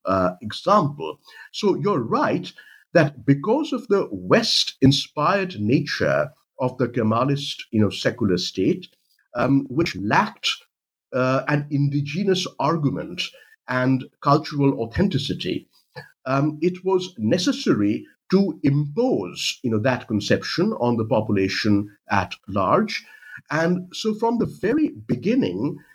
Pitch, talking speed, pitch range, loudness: 140 Hz, 115 wpm, 120-180 Hz, -22 LUFS